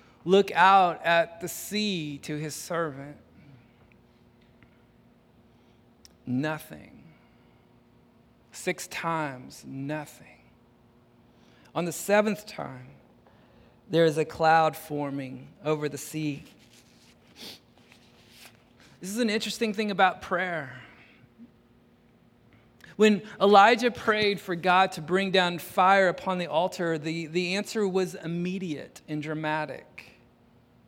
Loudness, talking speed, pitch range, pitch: -26 LUFS, 95 wpm, 150-190 Hz, 170 Hz